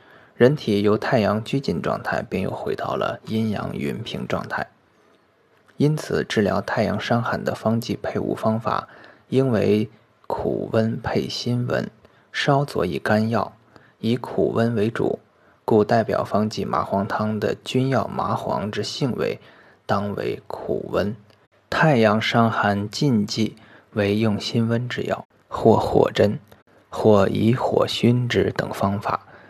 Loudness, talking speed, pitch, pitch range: -22 LUFS, 195 characters per minute, 110 Hz, 105-125 Hz